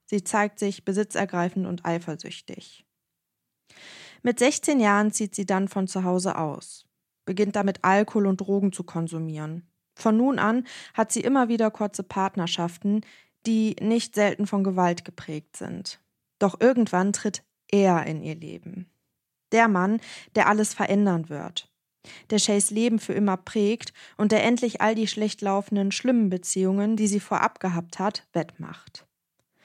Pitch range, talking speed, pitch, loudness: 180-215 Hz, 150 wpm, 200 Hz, -24 LUFS